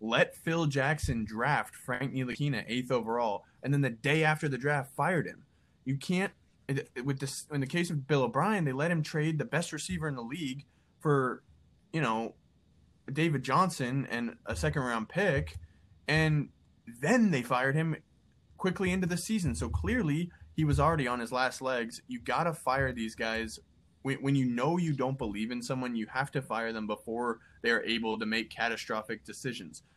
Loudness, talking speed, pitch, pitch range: -32 LUFS, 185 wpm, 135 Hz, 115-155 Hz